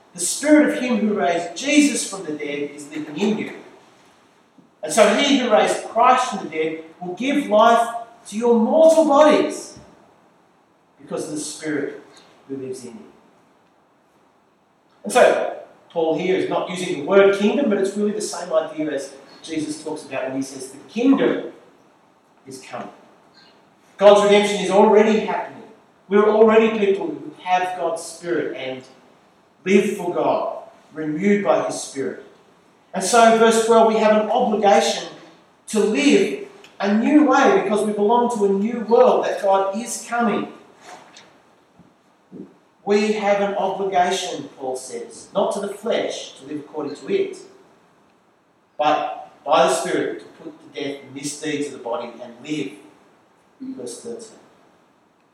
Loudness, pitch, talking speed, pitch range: -19 LUFS, 205 Hz, 155 wpm, 160-230 Hz